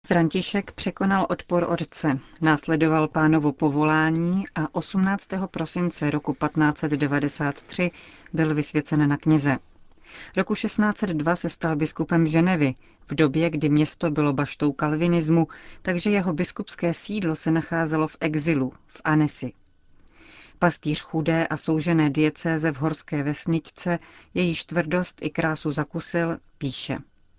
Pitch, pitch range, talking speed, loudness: 160 Hz, 150-170 Hz, 115 wpm, -24 LUFS